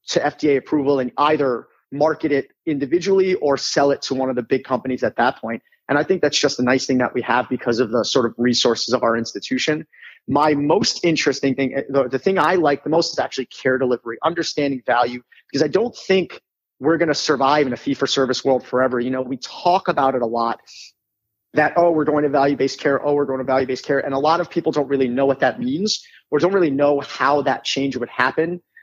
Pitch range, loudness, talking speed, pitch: 130-150 Hz, -19 LUFS, 240 wpm, 135 Hz